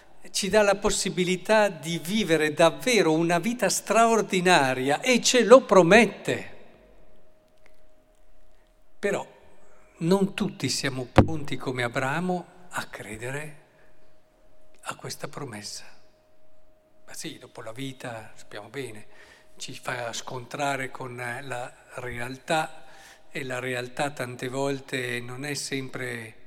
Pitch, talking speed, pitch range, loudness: 145 Hz, 105 wpm, 125-180 Hz, -25 LUFS